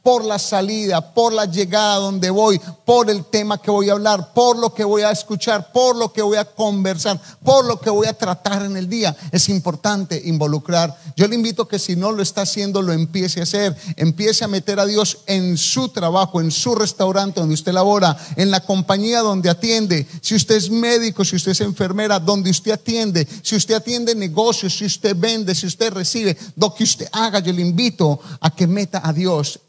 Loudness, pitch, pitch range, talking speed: -17 LUFS, 200 Hz, 180-215 Hz, 210 wpm